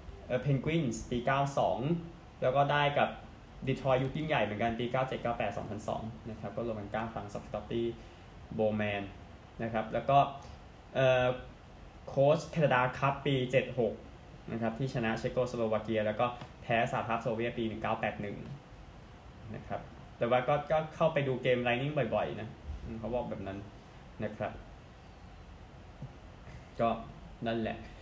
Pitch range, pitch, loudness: 110-135 Hz, 120 Hz, -33 LUFS